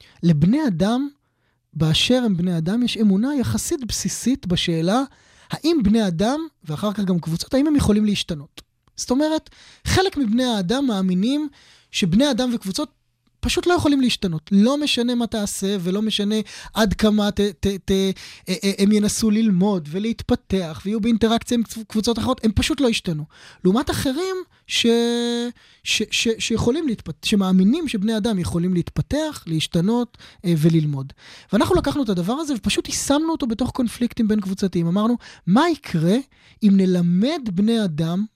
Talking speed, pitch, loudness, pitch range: 145 wpm, 215 Hz, -20 LUFS, 185-245 Hz